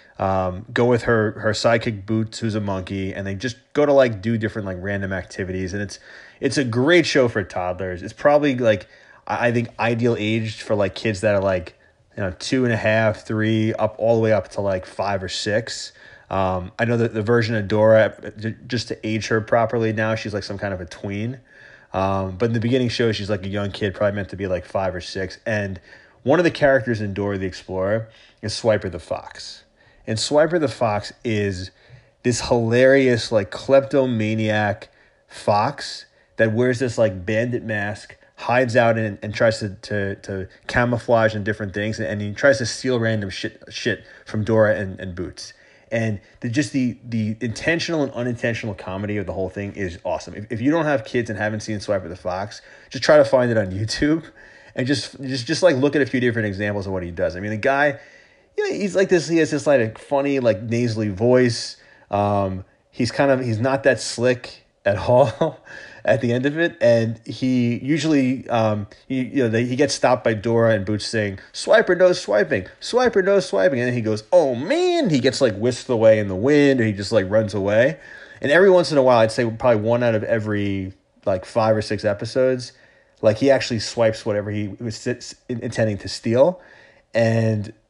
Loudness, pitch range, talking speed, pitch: -21 LUFS, 105-125 Hz, 210 wpm, 110 Hz